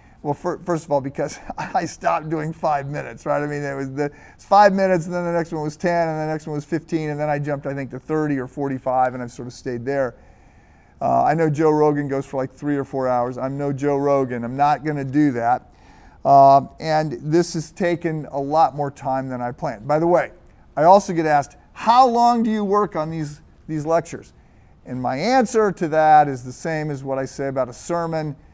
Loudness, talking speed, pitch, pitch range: -20 LUFS, 240 wpm, 145 Hz, 135-165 Hz